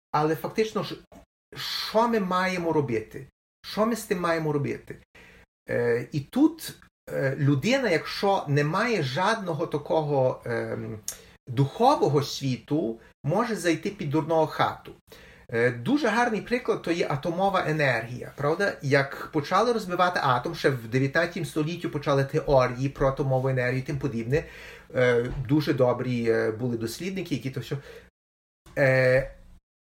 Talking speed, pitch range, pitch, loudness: 115 wpm, 130-175 Hz, 150 Hz, -26 LUFS